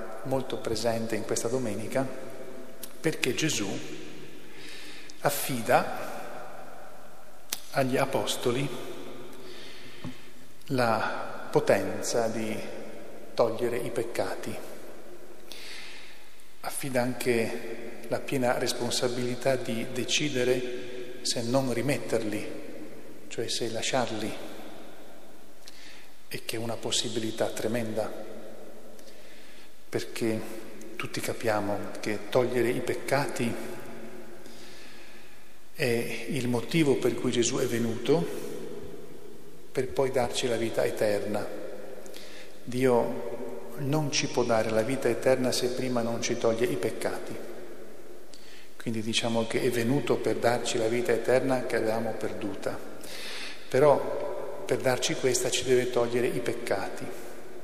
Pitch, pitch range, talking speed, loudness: 120 Hz, 115-125 Hz, 95 wpm, -29 LUFS